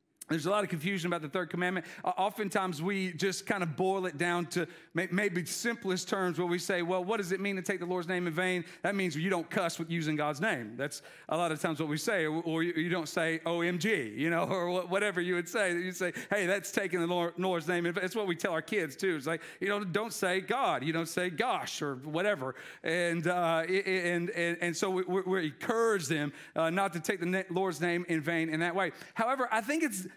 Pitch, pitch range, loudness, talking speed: 180 Hz, 170-195 Hz, -32 LUFS, 240 wpm